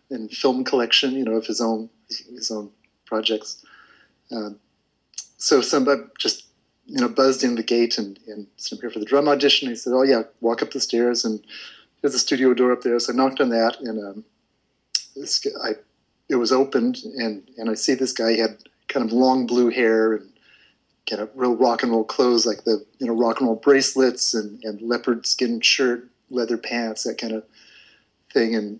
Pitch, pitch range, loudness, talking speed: 115 Hz, 110-125 Hz, -21 LUFS, 205 wpm